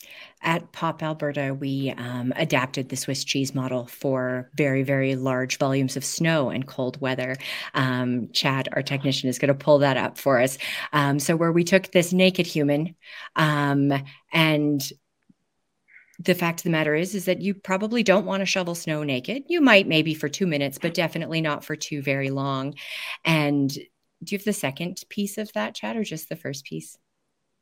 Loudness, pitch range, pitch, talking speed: -24 LUFS, 135-175 Hz, 150 Hz, 185 wpm